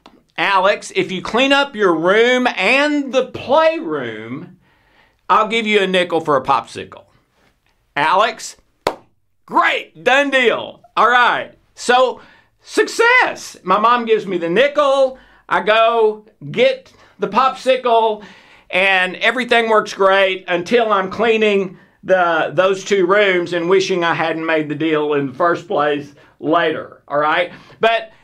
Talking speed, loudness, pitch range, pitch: 135 wpm, -15 LUFS, 180-250 Hz, 210 Hz